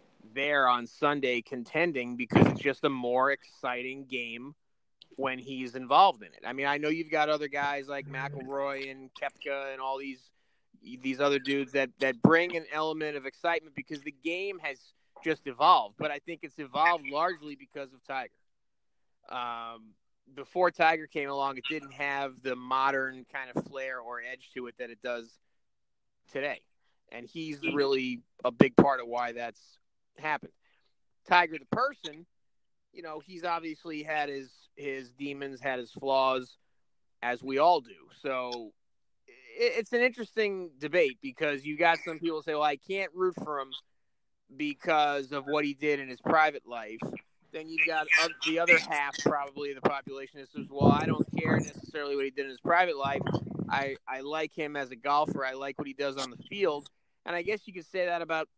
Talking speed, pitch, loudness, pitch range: 180 wpm, 140 Hz, -30 LUFS, 135-160 Hz